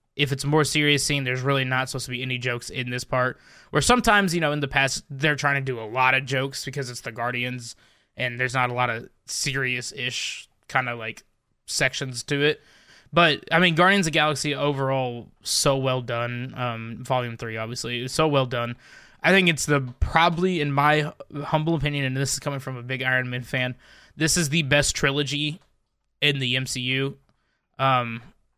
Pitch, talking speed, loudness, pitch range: 135 Hz, 200 wpm, -23 LUFS, 125-145 Hz